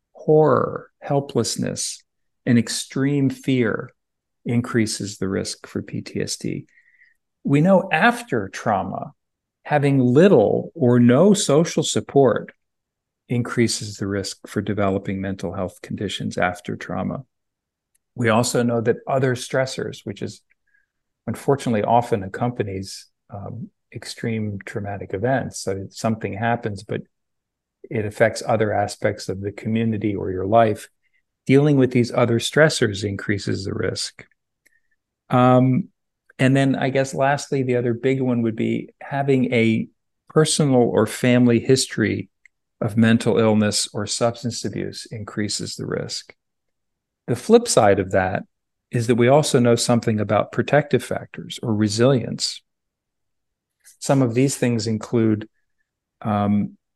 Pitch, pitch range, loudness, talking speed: 120 Hz, 110-135 Hz, -20 LUFS, 120 wpm